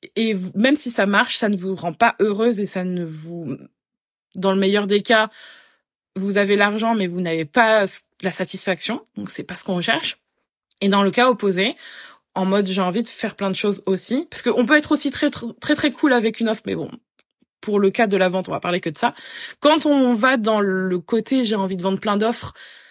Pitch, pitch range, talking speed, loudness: 205 Hz, 190-240 Hz, 235 wpm, -20 LUFS